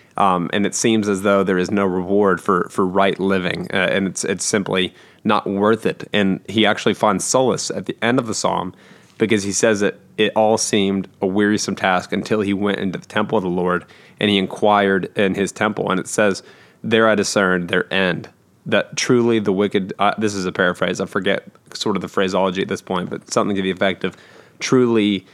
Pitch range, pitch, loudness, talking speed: 95-110 Hz, 100 Hz, -19 LUFS, 215 wpm